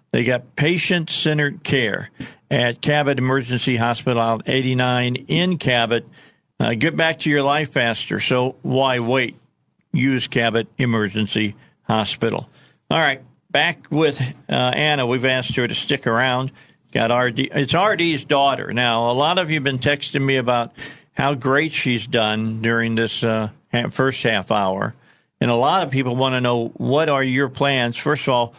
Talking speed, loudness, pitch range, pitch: 160 wpm, -19 LUFS, 120-145 Hz, 130 Hz